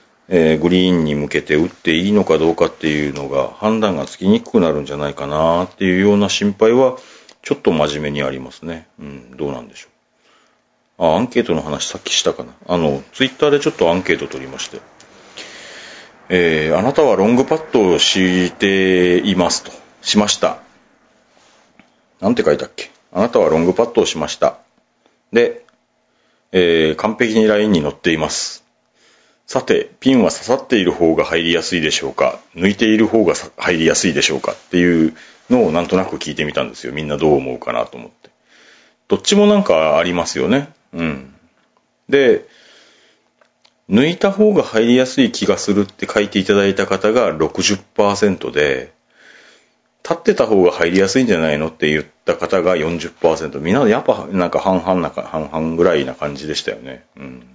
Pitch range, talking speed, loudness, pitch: 75-105 Hz, 360 characters per minute, -16 LUFS, 90 Hz